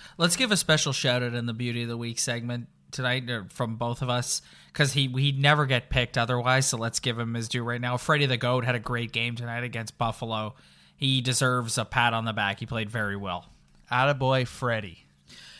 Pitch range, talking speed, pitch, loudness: 115-130 Hz, 215 wpm, 120 Hz, -26 LUFS